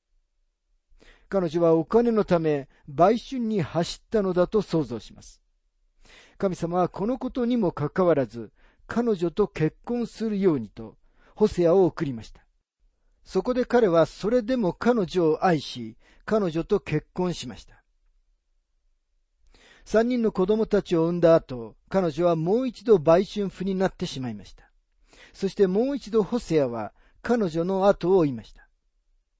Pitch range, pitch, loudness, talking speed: 130-210 Hz, 175 Hz, -24 LUFS, 270 characters per minute